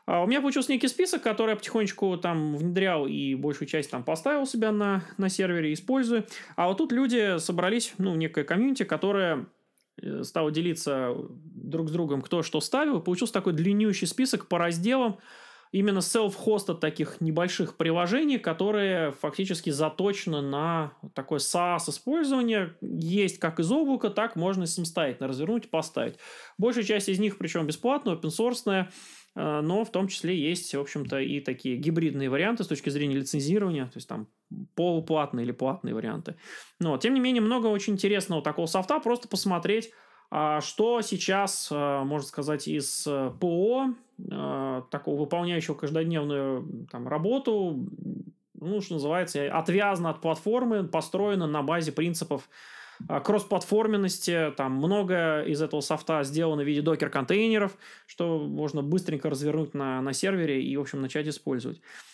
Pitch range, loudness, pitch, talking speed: 150-210 Hz, -28 LUFS, 175 Hz, 145 wpm